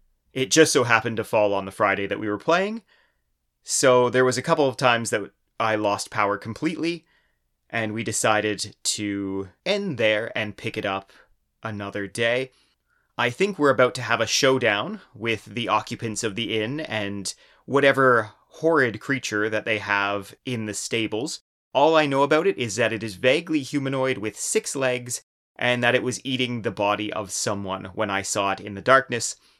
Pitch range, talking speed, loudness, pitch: 105-130 Hz, 185 wpm, -23 LUFS, 115 Hz